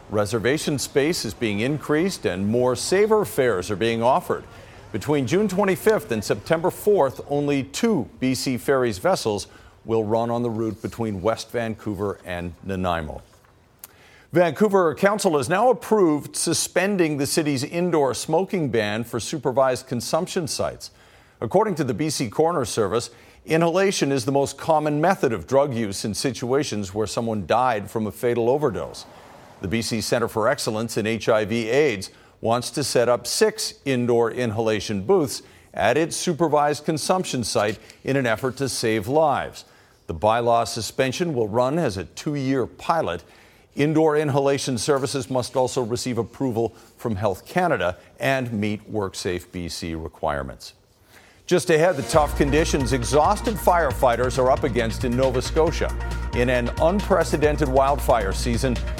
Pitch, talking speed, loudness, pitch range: 130 Hz, 145 wpm, -22 LUFS, 110-155 Hz